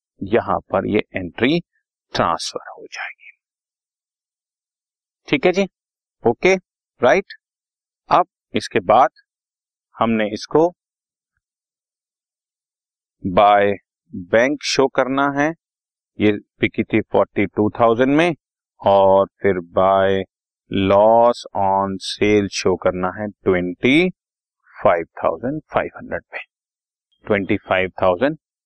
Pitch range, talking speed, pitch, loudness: 95-140 Hz, 100 wpm, 105 Hz, -18 LUFS